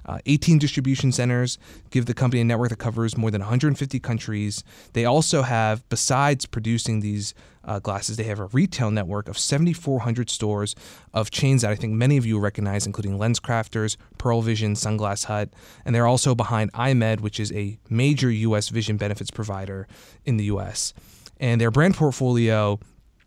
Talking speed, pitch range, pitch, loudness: 170 wpm, 105-125 Hz, 115 Hz, -23 LUFS